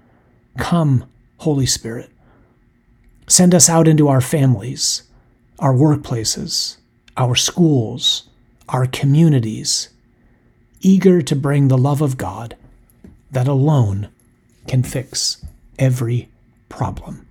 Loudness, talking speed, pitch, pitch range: -16 LUFS, 95 wpm, 130 Hz, 120-145 Hz